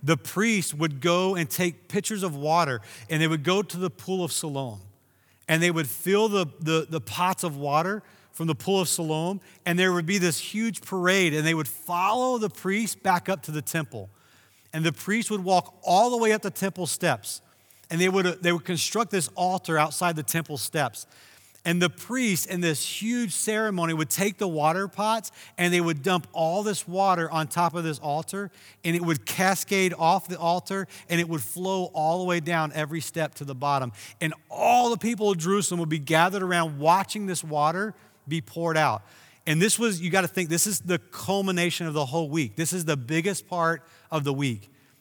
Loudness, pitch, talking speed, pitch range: -26 LUFS, 170 Hz, 210 wpm, 155-190 Hz